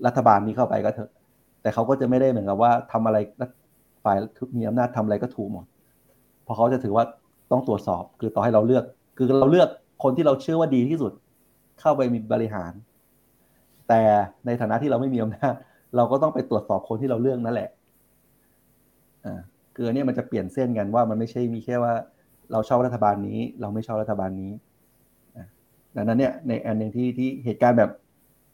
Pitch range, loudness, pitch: 110-125 Hz, -23 LUFS, 115 Hz